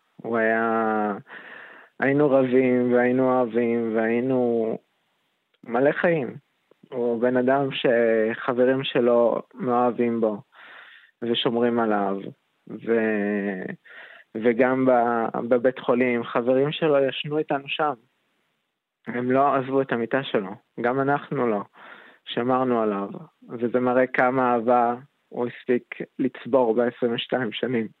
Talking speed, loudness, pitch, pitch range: 105 wpm, -23 LUFS, 120 Hz, 115-130 Hz